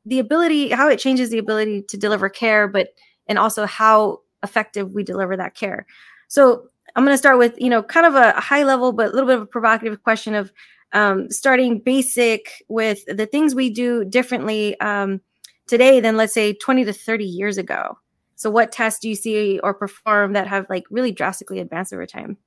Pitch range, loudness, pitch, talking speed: 205-250 Hz, -18 LUFS, 220 Hz, 200 wpm